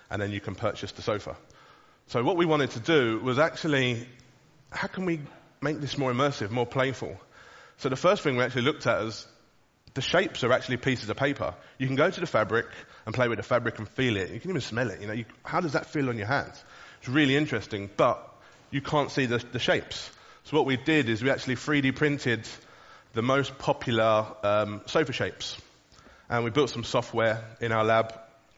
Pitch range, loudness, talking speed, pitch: 115-145 Hz, -28 LUFS, 215 wpm, 125 Hz